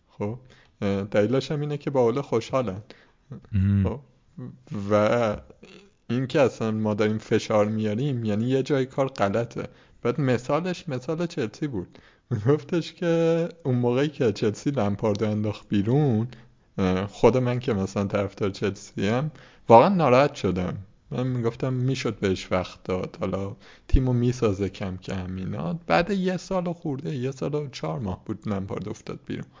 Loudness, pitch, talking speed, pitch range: -25 LUFS, 120 Hz, 145 wpm, 105-140 Hz